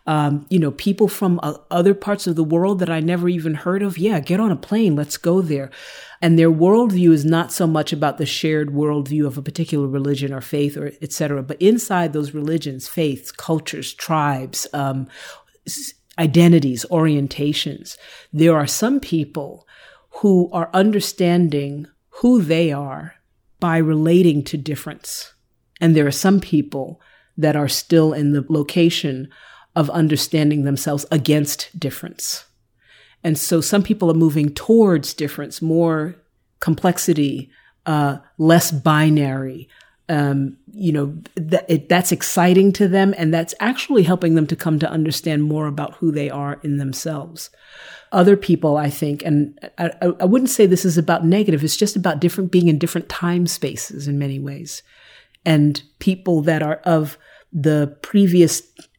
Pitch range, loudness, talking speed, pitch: 145-175 Hz, -18 LUFS, 155 wpm, 160 Hz